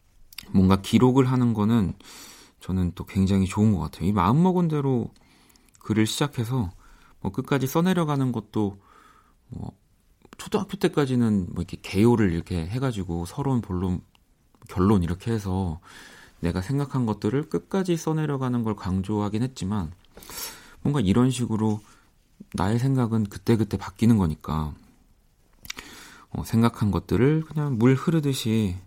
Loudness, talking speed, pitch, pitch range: -25 LUFS, 290 characters per minute, 110 Hz, 95-130 Hz